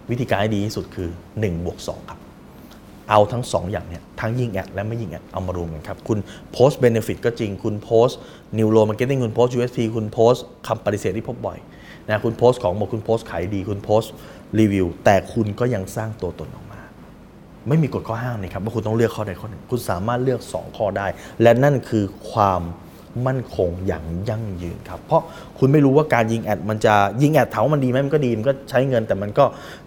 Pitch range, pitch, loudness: 100-120 Hz, 110 Hz, -21 LUFS